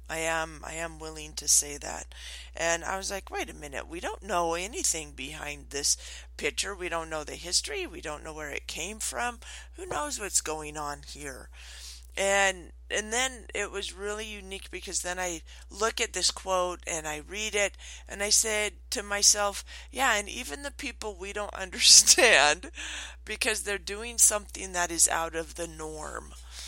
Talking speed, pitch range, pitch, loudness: 180 wpm, 155-205 Hz, 180 Hz, -26 LUFS